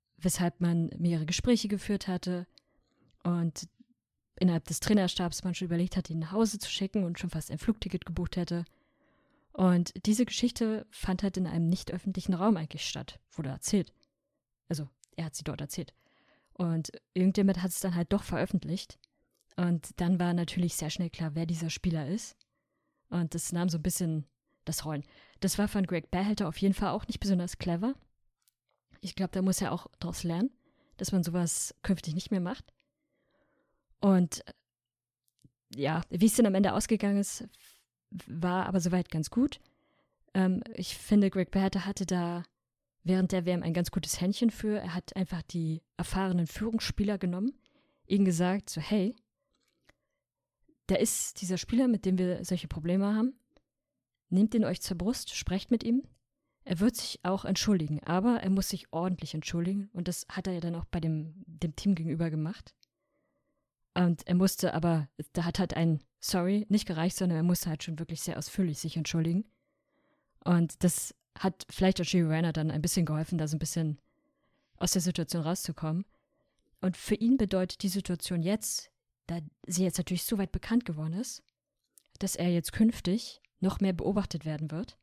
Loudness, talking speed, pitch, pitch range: -31 LUFS, 175 wpm, 180 Hz, 170-200 Hz